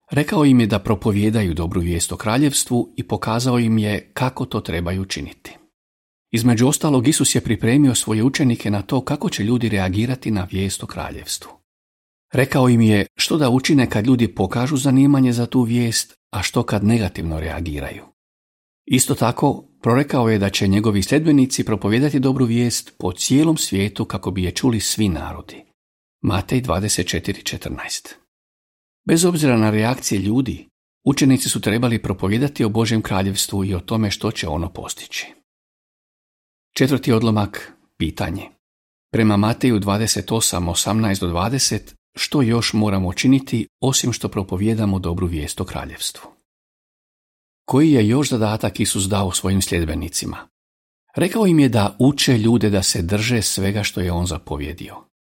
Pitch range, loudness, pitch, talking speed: 95-130 Hz, -19 LUFS, 110 Hz, 145 wpm